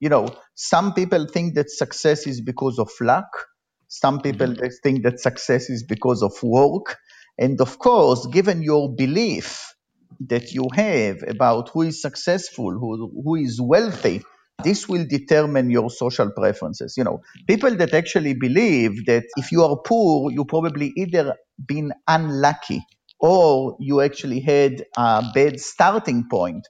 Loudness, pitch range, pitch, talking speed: -20 LUFS, 125-160 Hz, 140 Hz, 150 wpm